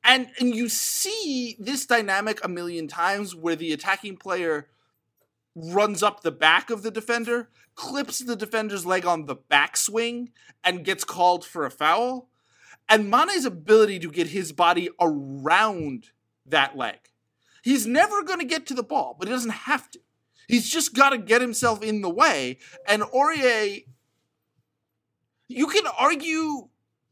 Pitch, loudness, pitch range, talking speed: 220 Hz, -23 LUFS, 175-255 Hz, 150 wpm